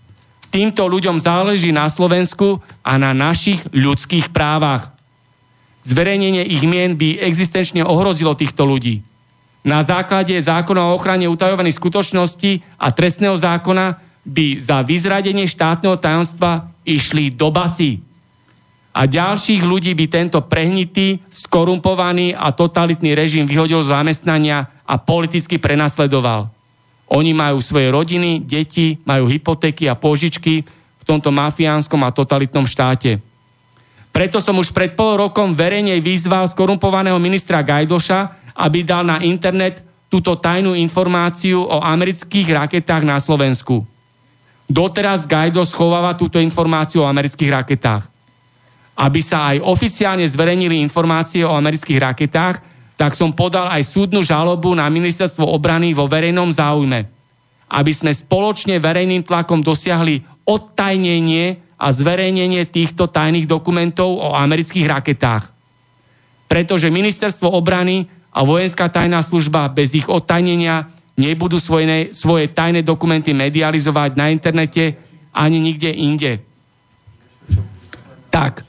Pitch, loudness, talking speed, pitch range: 165 Hz, -15 LUFS, 120 wpm, 145-180 Hz